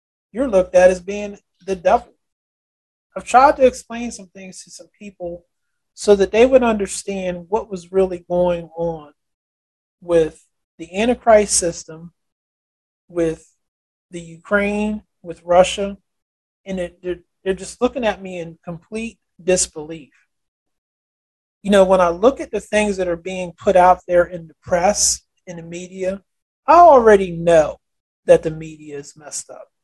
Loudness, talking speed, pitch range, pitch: -17 LUFS, 150 wpm, 170-205 Hz, 185 Hz